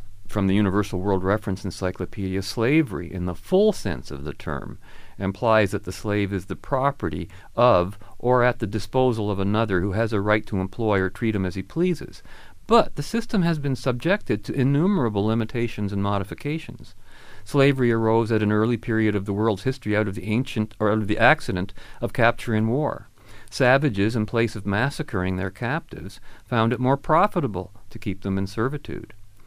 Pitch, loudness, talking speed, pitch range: 110 Hz, -23 LUFS, 185 wpm, 100-125 Hz